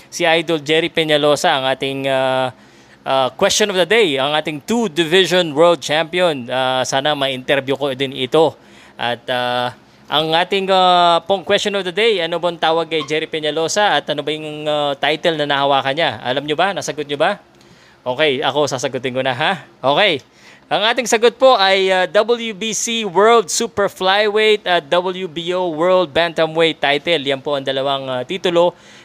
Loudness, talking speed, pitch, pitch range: -16 LUFS, 170 wpm, 160 Hz, 140-185 Hz